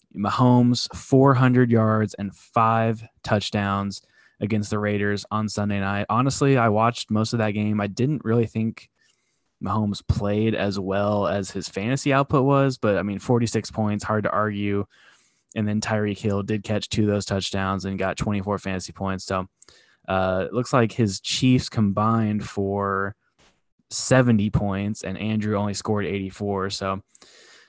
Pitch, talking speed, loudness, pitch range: 105 Hz, 155 wpm, -23 LUFS, 100-115 Hz